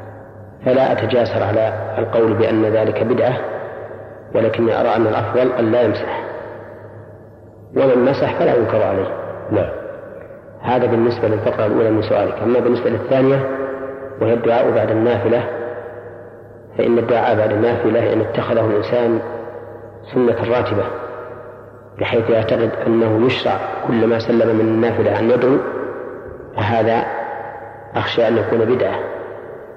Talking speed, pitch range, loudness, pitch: 115 wpm, 115-130 Hz, -17 LUFS, 120 Hz